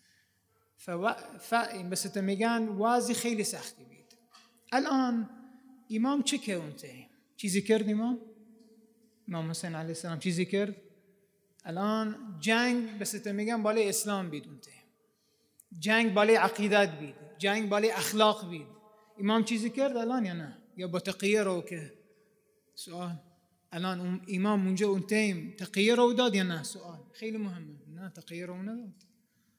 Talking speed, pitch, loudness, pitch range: 140 wpm, 210 Hz, -30 LUFS, 185-225 Hz